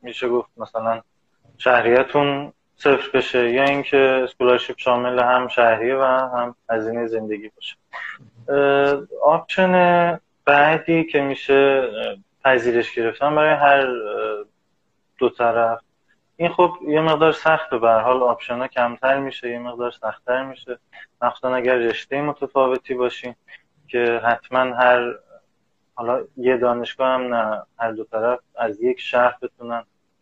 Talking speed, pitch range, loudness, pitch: 125 wpm, 120-140 Hz, -19 LUFS, 125 Hz